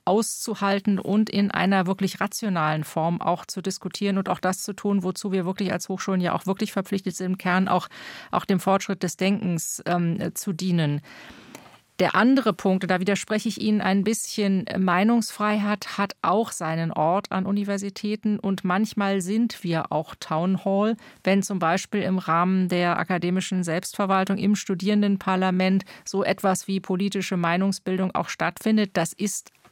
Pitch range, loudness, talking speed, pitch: 185-205 Hz, -24 LUFS, 160 wpm, 190 Hz